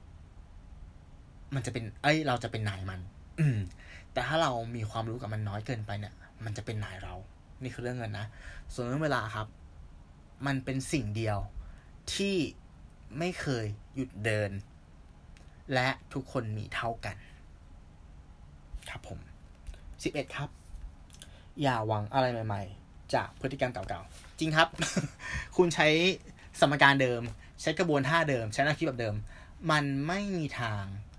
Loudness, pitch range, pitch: -31 LUFS, 80-130 Hz, 105 Hz